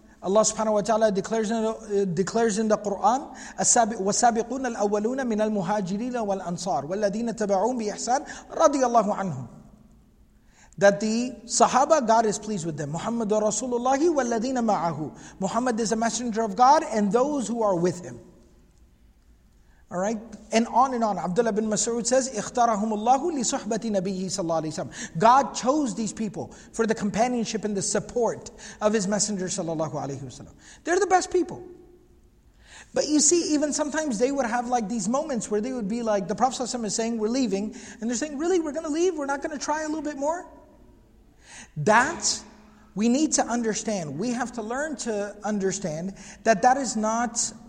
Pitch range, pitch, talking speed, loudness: 205-255 Hz, 225 Hz, 140 wpm, -25 LUFS